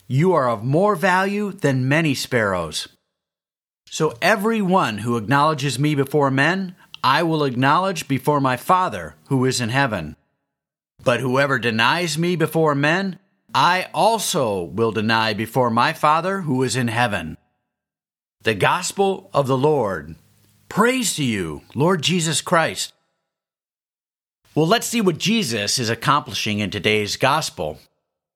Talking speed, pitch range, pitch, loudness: 135 wpm, 120-180 Hz, 145 Hz, -19 LUFS